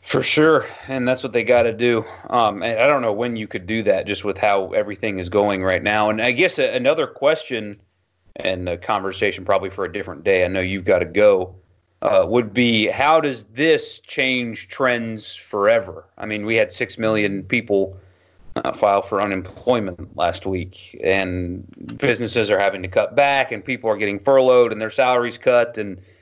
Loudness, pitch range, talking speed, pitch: -19 LUFS, 95-120 Hz, 195 wpm, 110 Hz